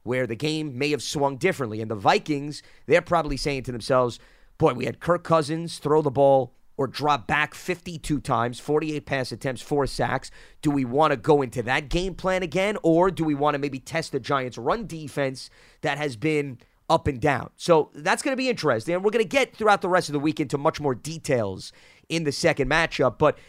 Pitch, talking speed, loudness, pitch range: 150 Hz, 220 wpm, -24 LUFS, 135-165 Hz